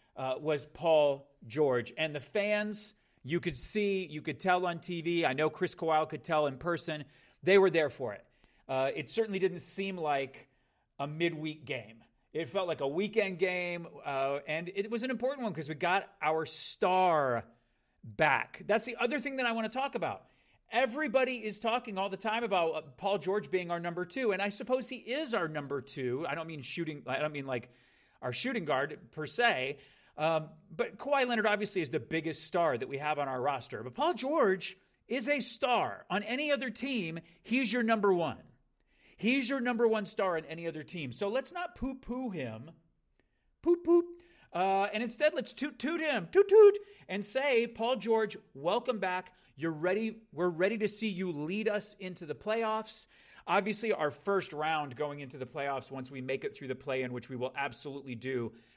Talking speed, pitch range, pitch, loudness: 195 wpm, 150-220 Hz, 180 Hz, -32 LUFS